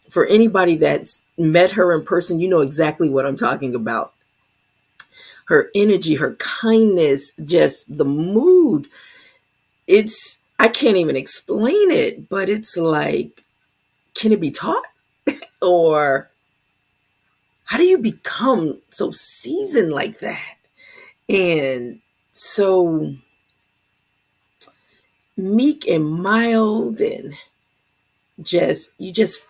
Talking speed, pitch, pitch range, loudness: 105 wpm, 190 Hz, 160-225 Hz, -17 LUFS